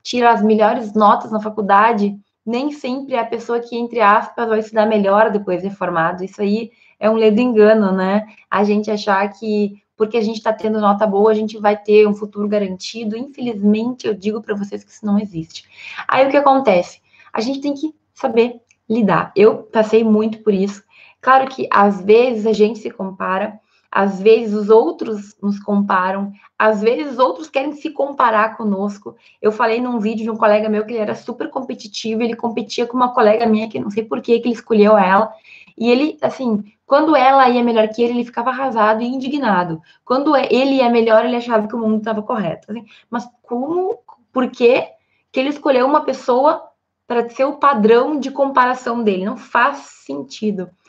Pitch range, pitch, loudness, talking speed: 210-245 Hz, 220 Hz, -16 LUFS, 195 wpm